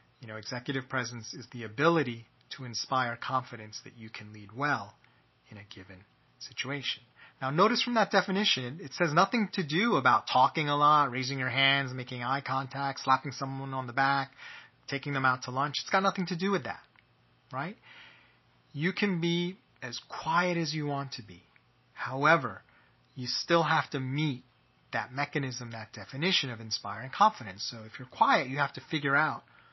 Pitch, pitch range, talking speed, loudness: 135 Hz, 125-155 Hz, 180 wpm, -29 LUFS